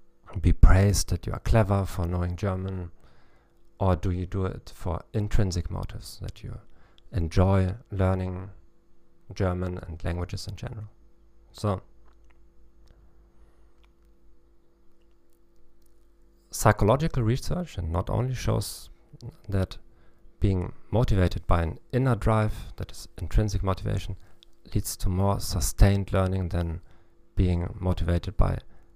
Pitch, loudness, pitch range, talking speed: 95 Hz, -27 LUFS, 80-105 Hz, 110 wpm